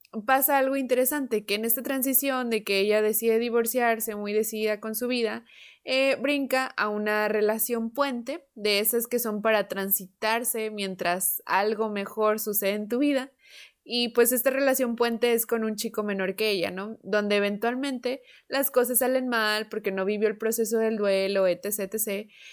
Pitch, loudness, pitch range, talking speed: 225 Hz, -25 LUFS, 210-250 Hz, 170 wpm